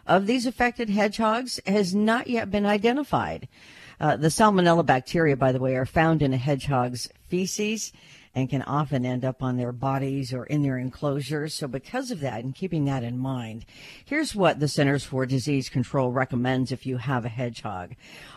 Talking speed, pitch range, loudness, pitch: 185 wpm, 130-190 Hz, -25 LUFS, 140 Hz